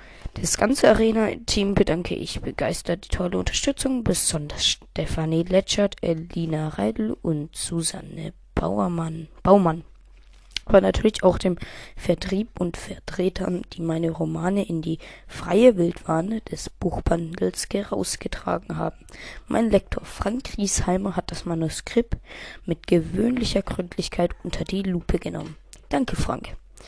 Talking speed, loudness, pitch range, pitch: 115 wpm, -24 LUFS, 165-200 Hz, 180 Hz